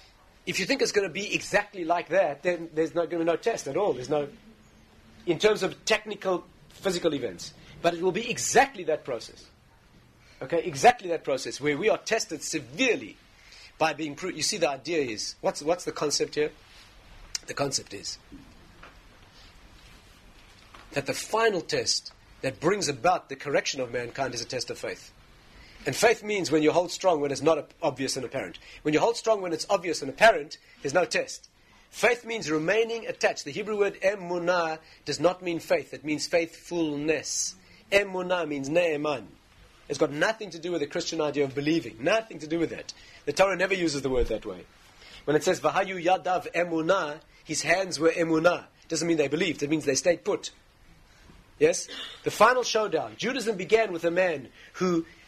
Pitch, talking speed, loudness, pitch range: 165 Hz, 190 wpm, -27 LUFS, 150-190 Hz